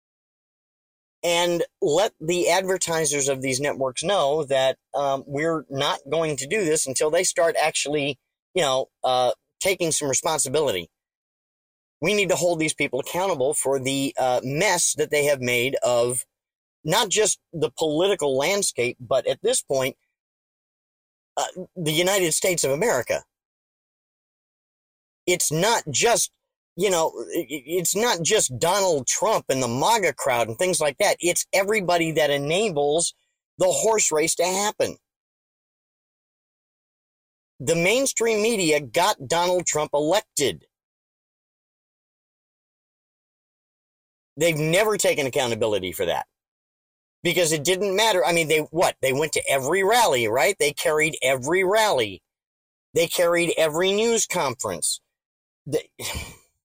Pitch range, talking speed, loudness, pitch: 140-190 Hz, 130 wpm, -22 LUFS, 165 Hz